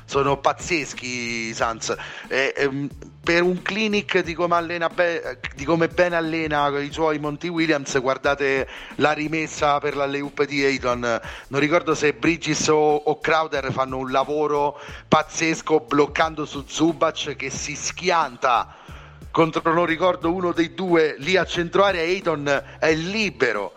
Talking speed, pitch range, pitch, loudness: 145 wpm, 140-165 Hz, 155 Hz, -22 LUFS